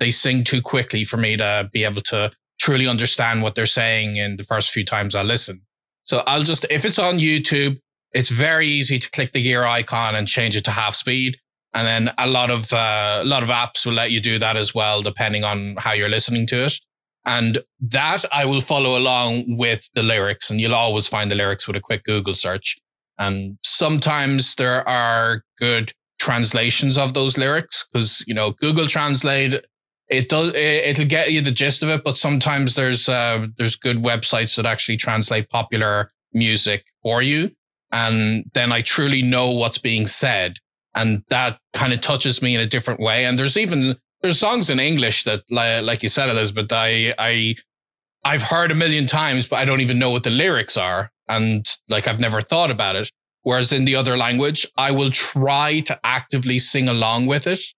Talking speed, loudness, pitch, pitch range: 200 wpm, -18 LUFS, 120 Hz, 110-135 Hz